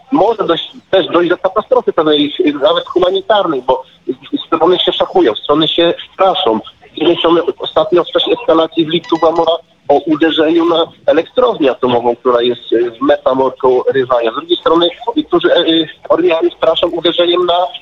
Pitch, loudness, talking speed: 175 Hz, -12 LUFS, 140 wpm